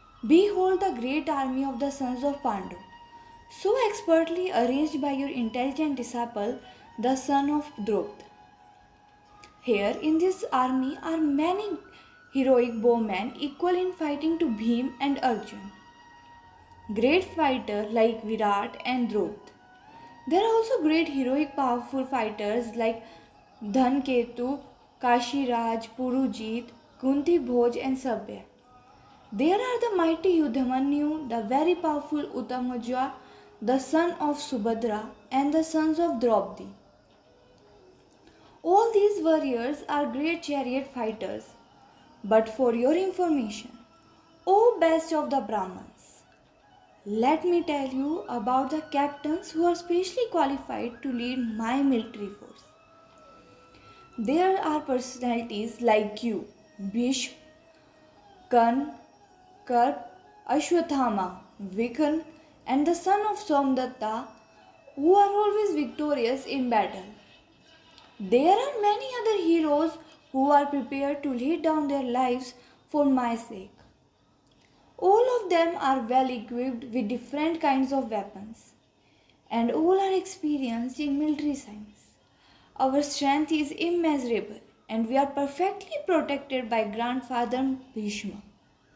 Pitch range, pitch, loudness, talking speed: 240-315 Hz, 270 Hz, -27 LUFS, 120 wpm